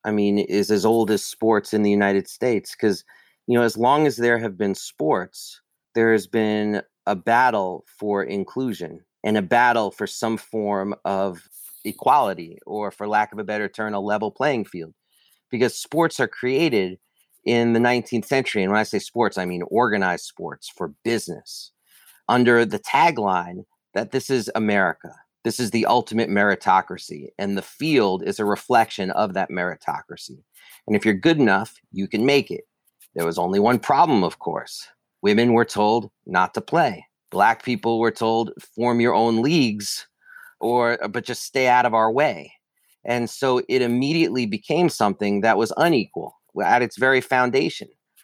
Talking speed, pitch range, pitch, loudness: 170 wpm, 100-120 Hz, 110 Hz, -21 LUFS